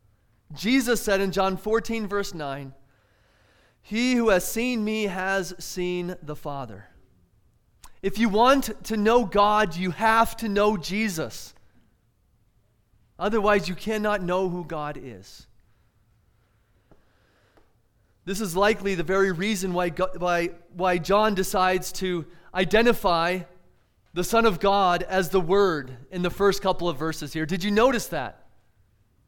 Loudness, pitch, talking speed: -24 LUFS, 180 Hz, 135 wpm